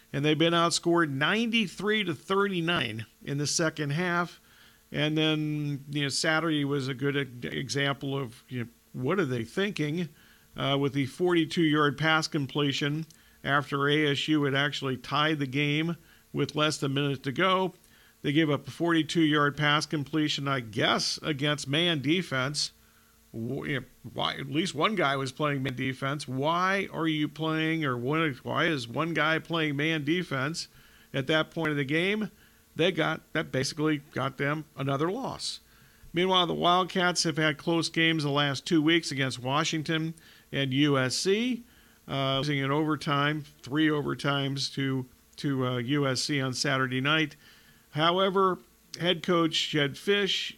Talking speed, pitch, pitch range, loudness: 160 wpm, 150 Hz, 140-165 Hz, -28 LUFS